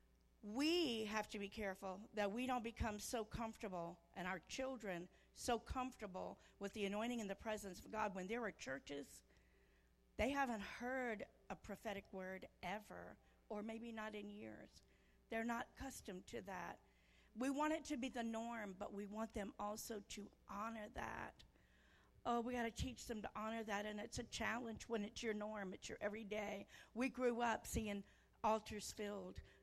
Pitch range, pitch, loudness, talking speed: 200-235 Hz, 215 Hz, -47 LUFS, 175 wpm